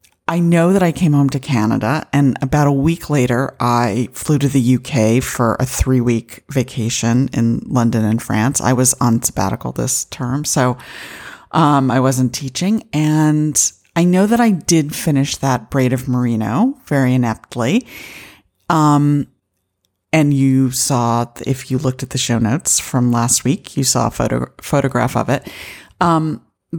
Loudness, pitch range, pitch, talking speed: -16 LUFS, 120-150 Hz, 130 Hz, 165 wpm